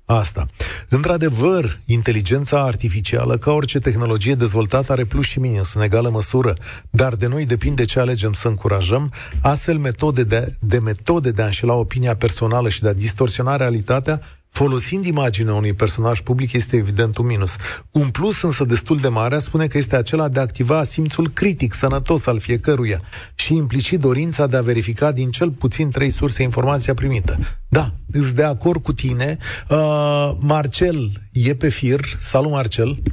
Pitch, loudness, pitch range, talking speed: 130 Hz, -18 LUFS, 115-145 Hz, 165 wpm